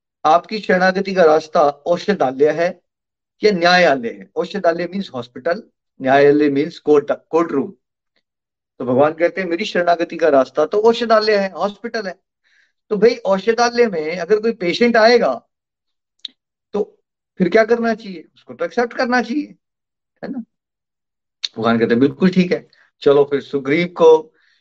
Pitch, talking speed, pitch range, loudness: 185 Hz, 140 wpm, 155-225 Hz, -16 LUFS